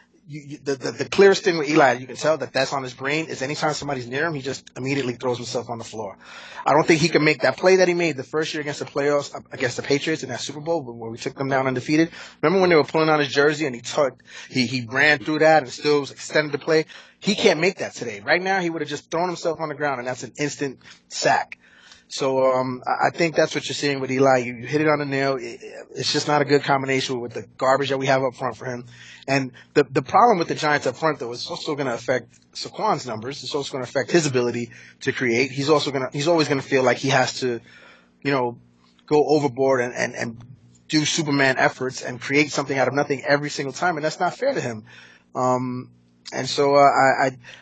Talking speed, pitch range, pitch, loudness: 255 wpm, 130-155 Hz, 140 Hz, -21 LUFS